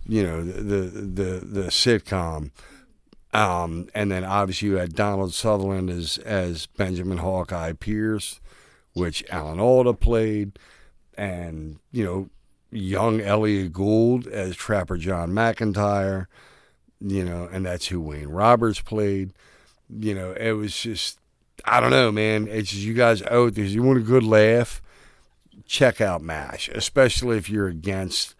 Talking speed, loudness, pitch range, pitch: 145 wpm, -23 LUFS, 90-110 Hz, 100 Hz